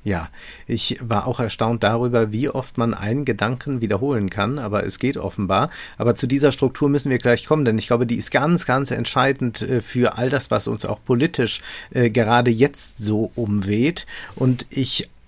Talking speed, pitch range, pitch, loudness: 180 wpm, 110-135 Hz, 120 Hz, -21 LUFS